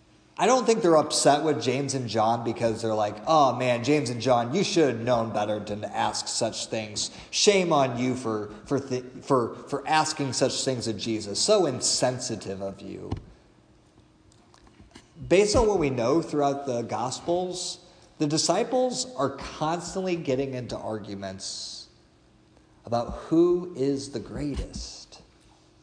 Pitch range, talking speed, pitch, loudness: 110-155 Hz, 145 wpm, 125 Hz, -26 LUFS